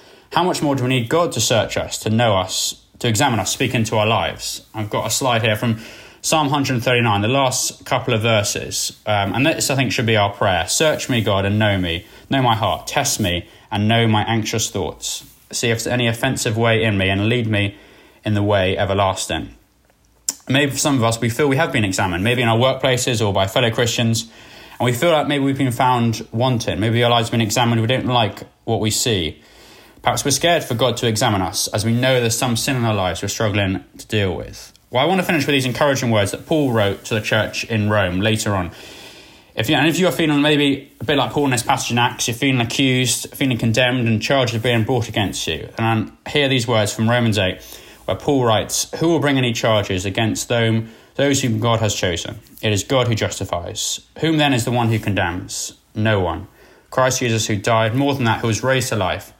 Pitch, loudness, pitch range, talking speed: 115 Hz, -18 LUFS, 105-130 Hz, 235 wpm